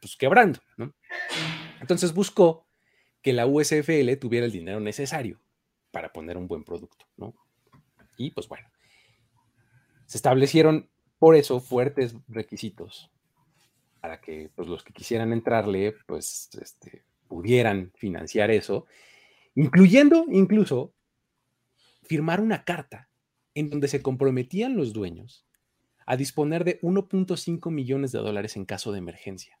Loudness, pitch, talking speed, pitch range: -23 LUFS, 130 Hz, 125 wpm, 115-160 Hz